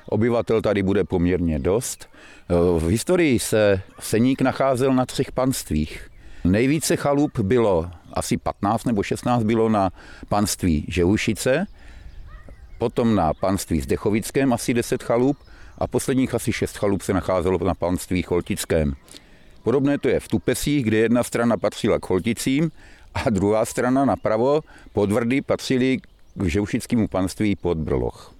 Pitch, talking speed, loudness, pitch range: 110 Hz, 135 wpm, -22 LUFS, 90-130 Hz